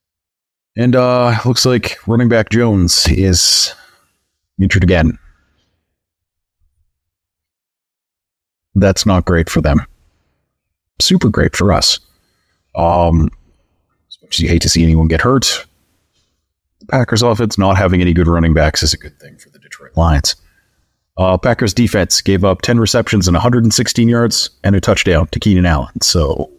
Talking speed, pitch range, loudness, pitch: 145 wpm, 80-110 Hz, -12 LUFS, 90 Hz